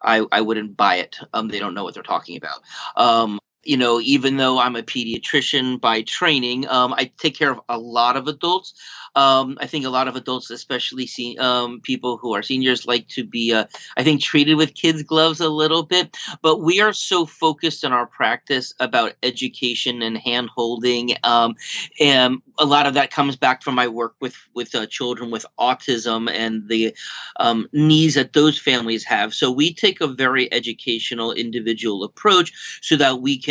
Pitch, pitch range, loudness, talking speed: 125 Hz, 120-145 Hz, -19 LUFS, 195 wpm